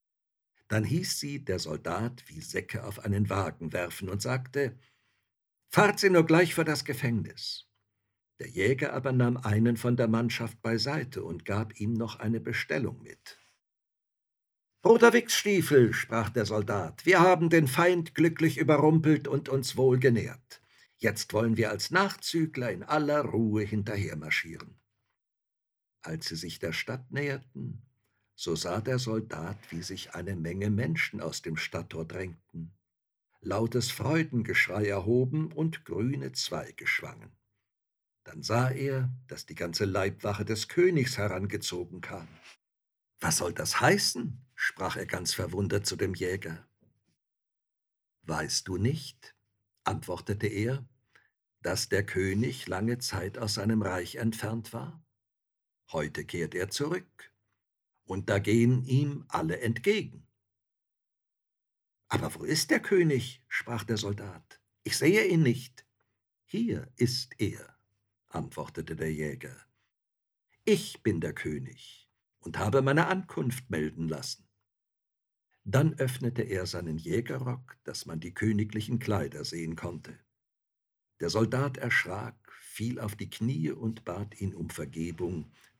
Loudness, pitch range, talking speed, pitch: -29 LUFS, 100-130 Hz, 130 wpm, 115 Hz